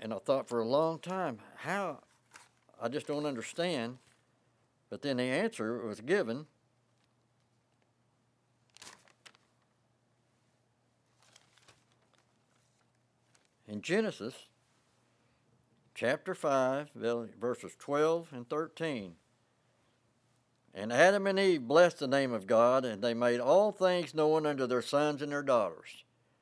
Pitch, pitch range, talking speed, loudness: 125 Hz, 120-150 Hz, 105 wpm, -32 LUFS